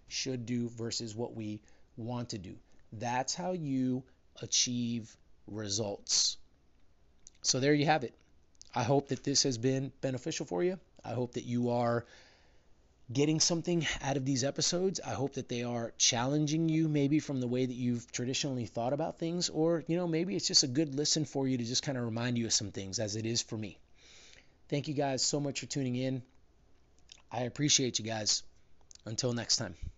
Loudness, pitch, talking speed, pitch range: -32 LUFS, 125 Hz, 190 wpm, 110-140 Hz